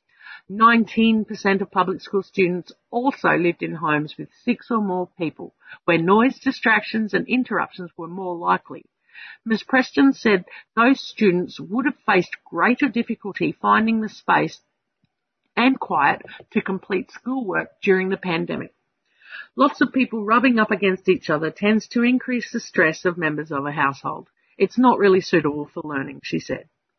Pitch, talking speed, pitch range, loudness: 200 Hz, 155 wpm, 180-235 Hz, -21 LUFS